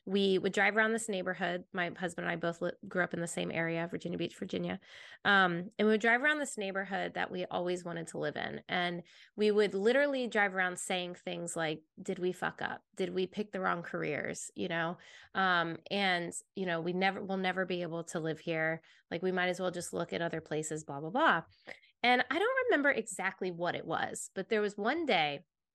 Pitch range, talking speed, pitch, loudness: 170-200 Hz, 225 wpm, 185 Hz, -33 LUFS